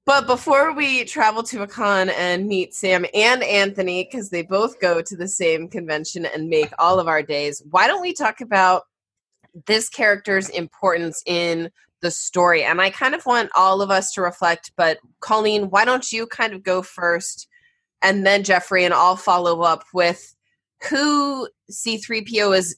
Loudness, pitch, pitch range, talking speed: -19 LUFS, 190 Hz, 175-225 Hz, 175 wpm